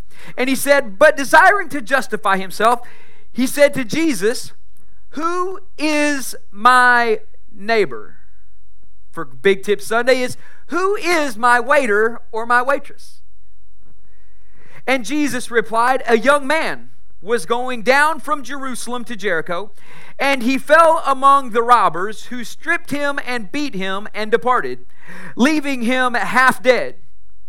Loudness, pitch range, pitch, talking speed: -17 LUFS, 205-285 Hz, 245 Hz, 130 wpm